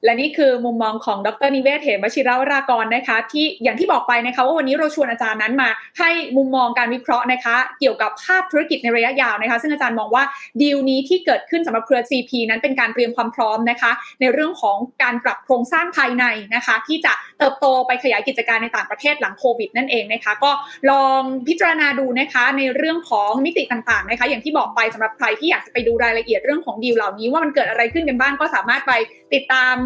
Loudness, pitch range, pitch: -18 LUFS, 235-280 Hz, 255 Hz